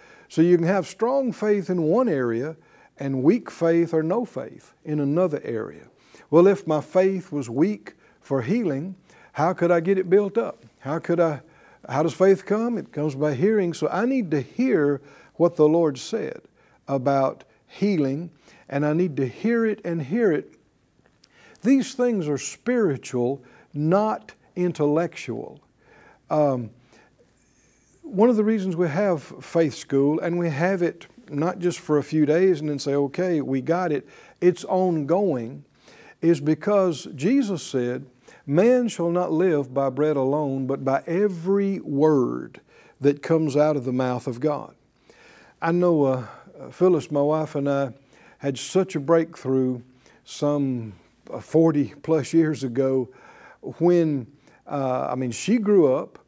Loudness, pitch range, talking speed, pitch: -23 LUFS, 140-185 Hz, 155 wpm, 160 Hz